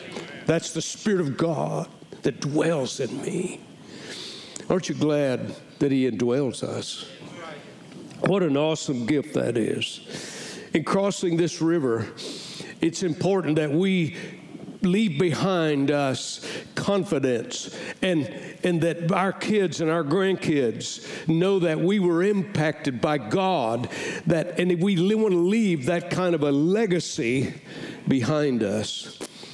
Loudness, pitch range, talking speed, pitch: -25 LUFS, 150-185 Hz, 130 wpm, 170 Hz